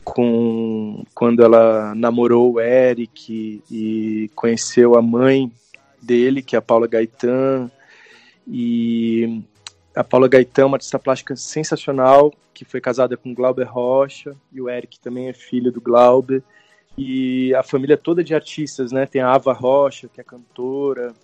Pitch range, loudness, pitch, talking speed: 120-135 Hz, -17 LUFS, 125 Hz, 155 wpm